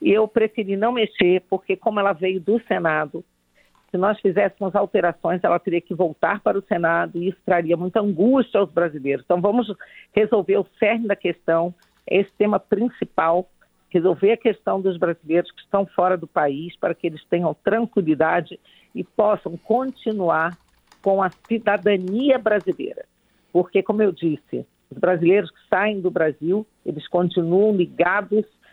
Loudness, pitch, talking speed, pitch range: -21 LUFS, 195 Hz, 155 wpm, 175-215 Hz